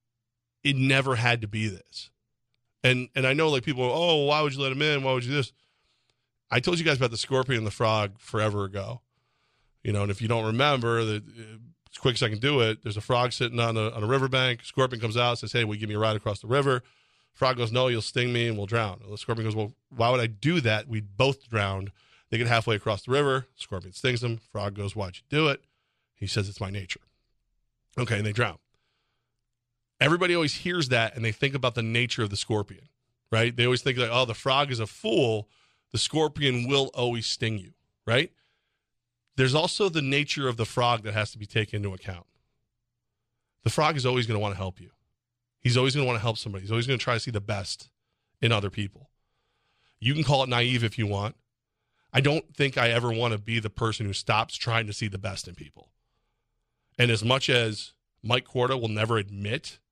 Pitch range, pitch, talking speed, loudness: 110-130 Hz, 120 Hz, 230 wpm, -26 LUFS